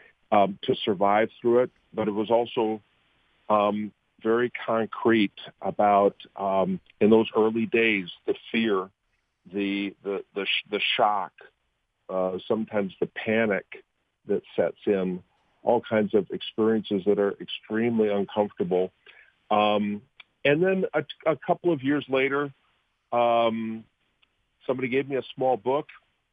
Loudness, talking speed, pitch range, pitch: -26 LUFS, 130 wpm, 100-120 Hz, 110 Hz